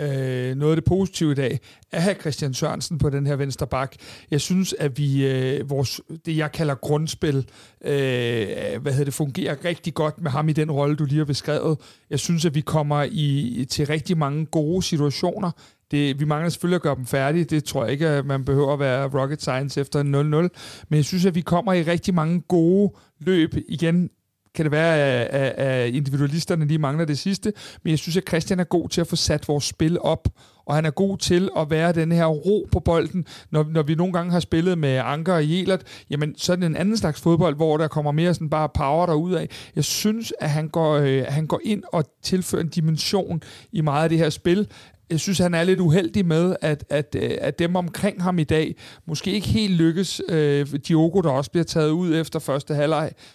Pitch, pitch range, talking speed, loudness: 155 Hz, 145-170 Hz, 220 wpm, -22 LUFS